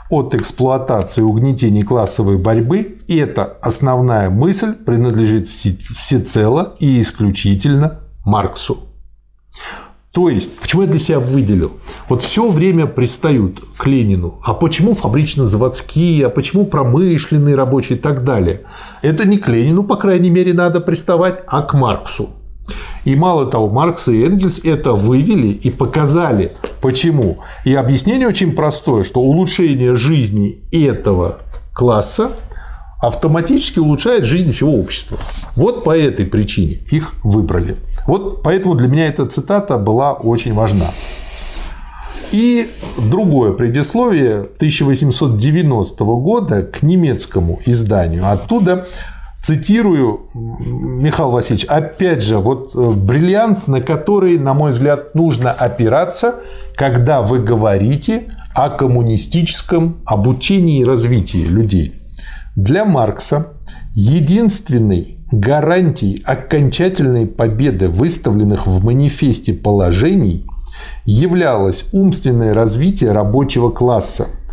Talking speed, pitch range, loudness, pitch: 110 wpm, 110-165 Hz, -14 LUFS, 130 Hz